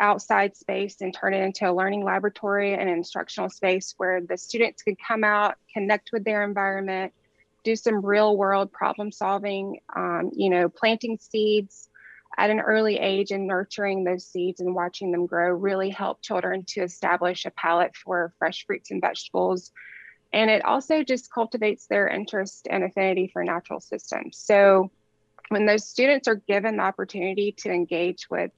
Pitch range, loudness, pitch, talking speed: 185-210 Hz, -24 LUFS, 195 Hz, 170 wpm